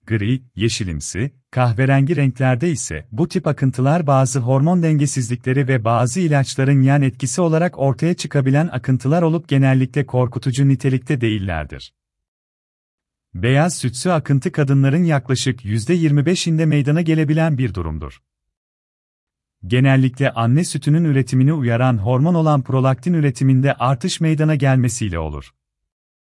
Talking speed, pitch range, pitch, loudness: 110 wpm, 120-150 Hz, 135 Hz, -17 LUFS